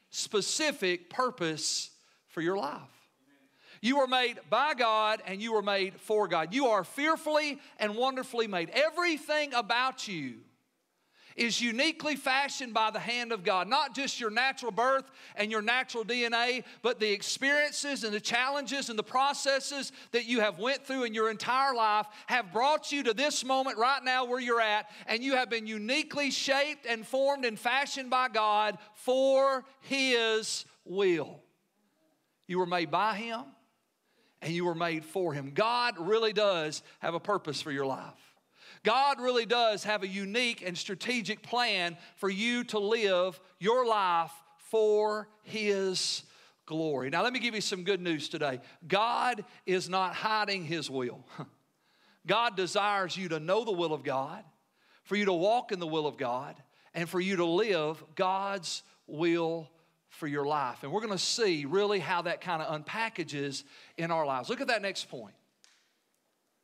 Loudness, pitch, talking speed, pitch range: -30 LUFS, 215 Hz, 165 wpm, 180-255 Hz